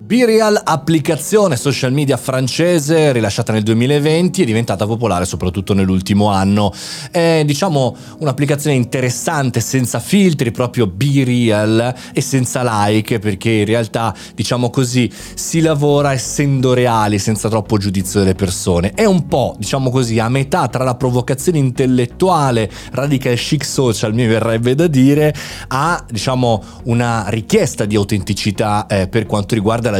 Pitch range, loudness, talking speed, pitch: 110-145 Hz, -15 LUFS, 135 wpm, 125 Hz